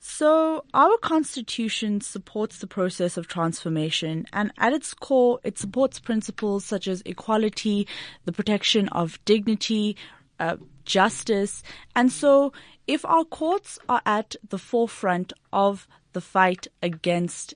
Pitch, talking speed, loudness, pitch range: 210 Hz, 125 wpm, -24 LUFS, 185-240 Hz